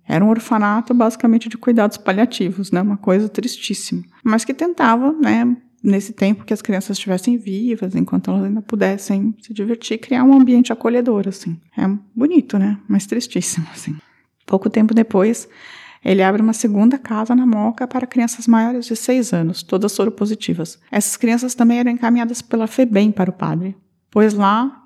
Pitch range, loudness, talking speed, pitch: 200-240 Hz, -17 LUFS, 170 wpm, 220 Hz